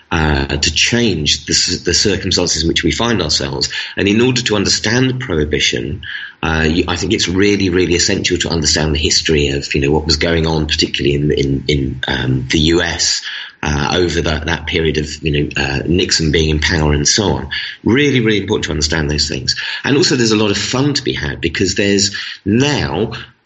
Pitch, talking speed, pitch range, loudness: 85 Hz, 200 wpm, 75-100 Hz, -14 LUFS